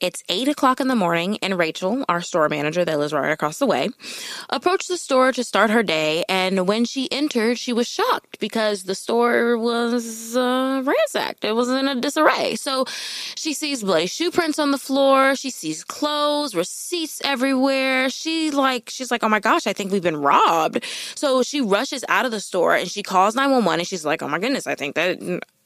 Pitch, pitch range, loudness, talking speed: 245 Hz, 190-275 Hz, -21 LUFS, 210 wpm